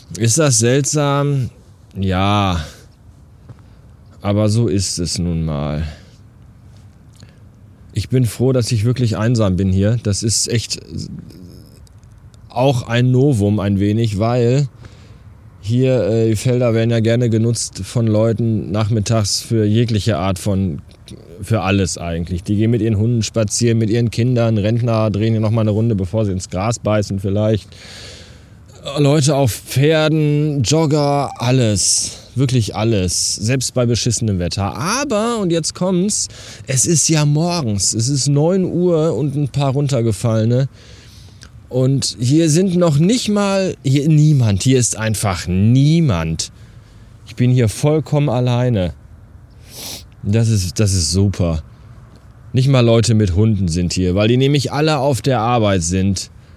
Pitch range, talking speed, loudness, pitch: 100-130 Hz, 140 wpm, -16 LUFS, 115 Hz